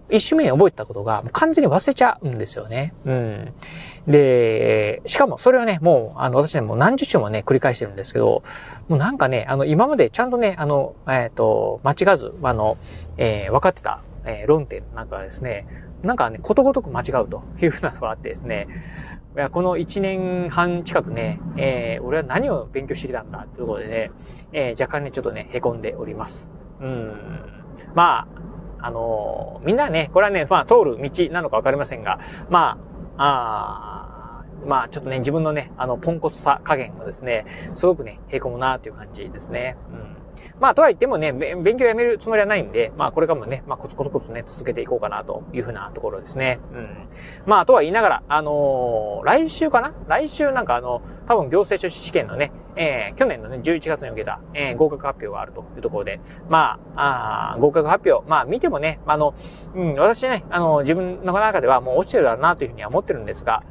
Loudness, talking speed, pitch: -20 LUFS, 400 characters per minute, 160 Hz